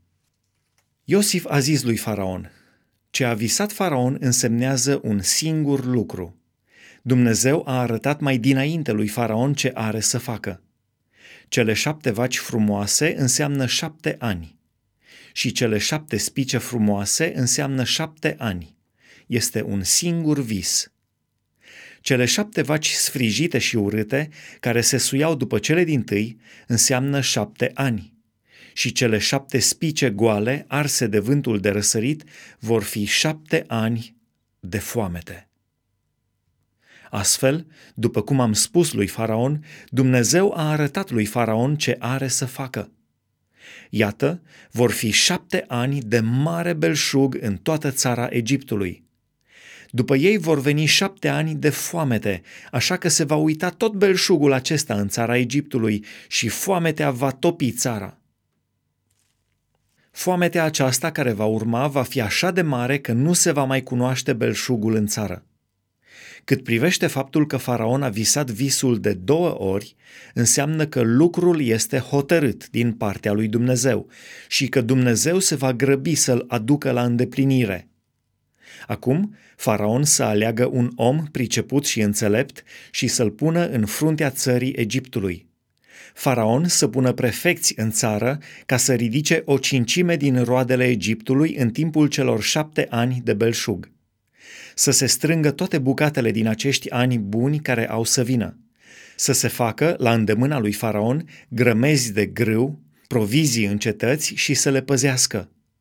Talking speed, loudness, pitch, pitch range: 140 wpm, -20 LUFS, 125 Hz, 110-150 Hz